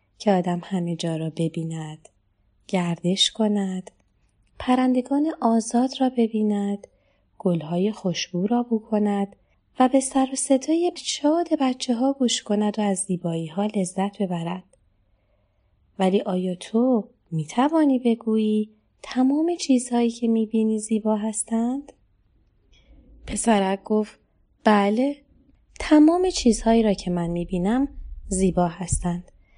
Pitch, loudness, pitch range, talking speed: 215 Hz, -23 LUFS, 180-250 Hz, 115 wpm